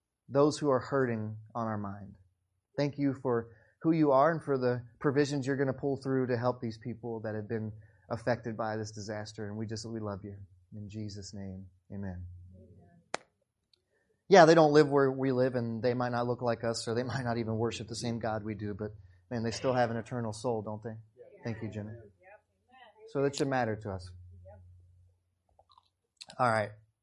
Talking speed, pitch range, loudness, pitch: 200 wpm, 105-125 Hz, -31 LUFS, 115 Hz